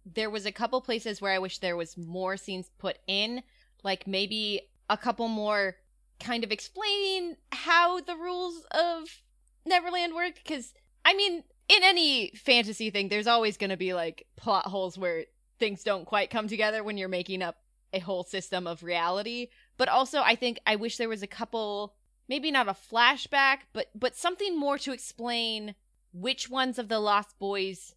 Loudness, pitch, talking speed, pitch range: -28 LUFS, 220 Hz, 180 wpm, 195-270 Hz